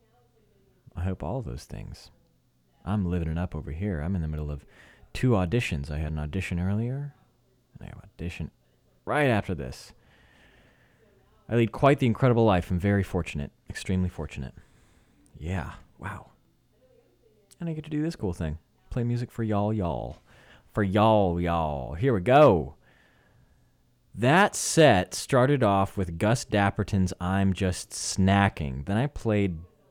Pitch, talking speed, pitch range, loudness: 100 Hz, 150 wpm, 85-115 Hz, -26 LUFS